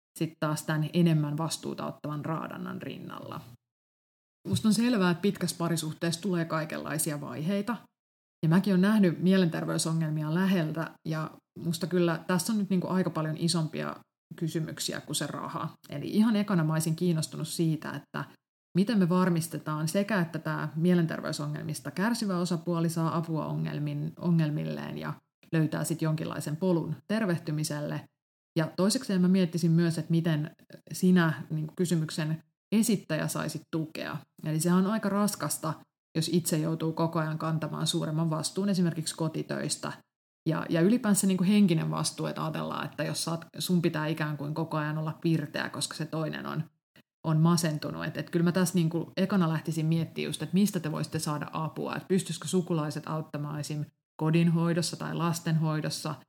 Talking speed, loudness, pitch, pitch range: 150 wpm, -29 LUFS, 160 Hz, 155-180 Hz